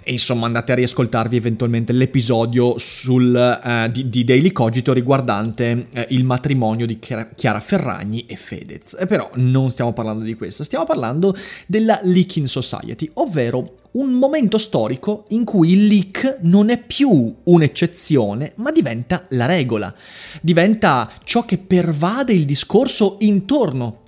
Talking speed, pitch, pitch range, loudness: 140 wpm, 135 Hz, 120-190 Hz, -17 LUFS